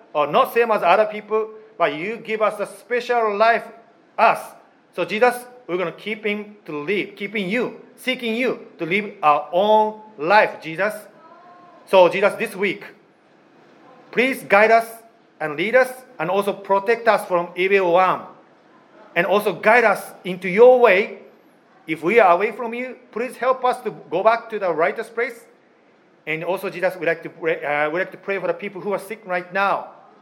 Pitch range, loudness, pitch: 185-235 Hz, -20 LUFS, 210 Hz